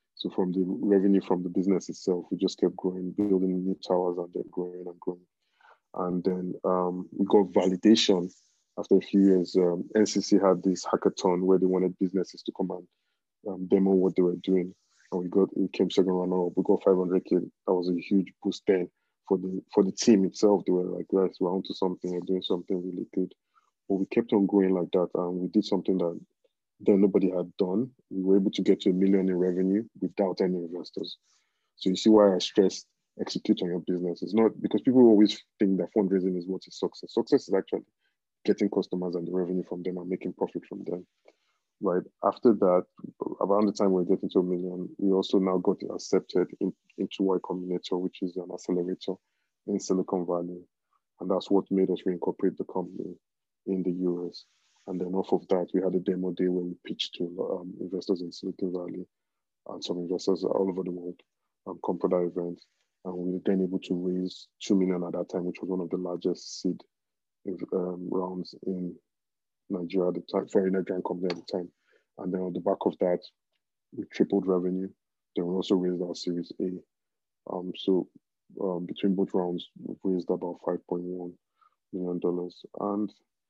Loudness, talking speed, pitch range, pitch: -28 LUFS, 200 wpm, 90-95 Hz, 95 Hz